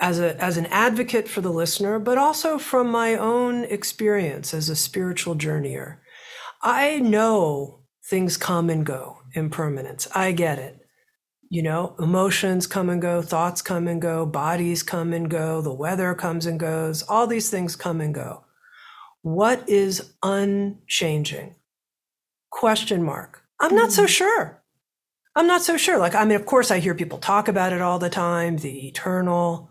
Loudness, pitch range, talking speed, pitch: -22 LUFS, 165-220 Hz, 165 wpm, 180 Hz